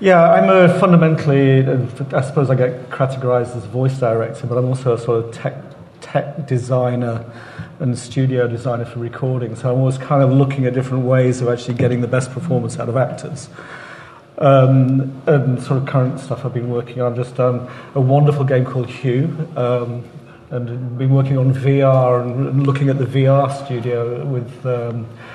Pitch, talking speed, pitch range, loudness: 130 Hz, 180 wpm, 125-135 Hz, -17 LUFS